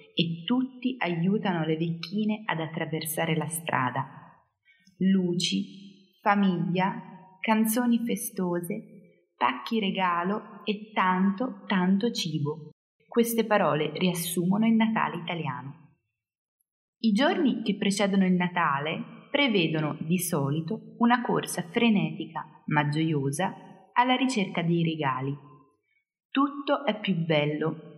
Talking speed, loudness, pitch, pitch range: 100 wpm, -27 LUFS, 185 Hz, 160-215 Hz